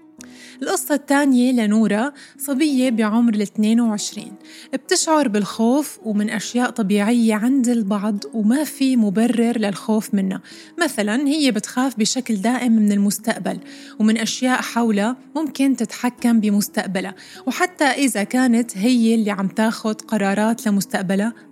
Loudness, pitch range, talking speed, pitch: -19 LUFS, 215-260 Hz, 110 wpm, 230 Hz